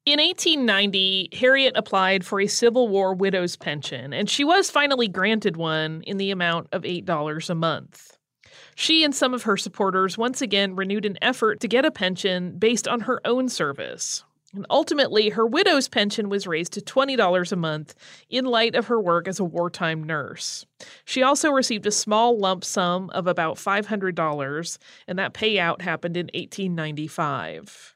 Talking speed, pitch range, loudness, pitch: 170 wpm, 175-235 Hz, -22 LUFS, 200 Hz